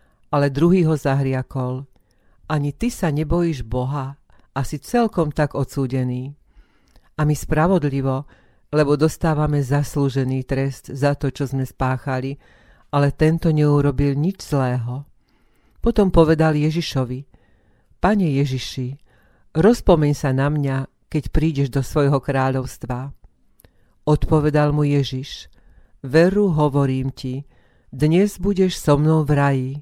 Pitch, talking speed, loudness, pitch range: 140 Hz, 115 wpm, -20 LUFS, 130-155 Hz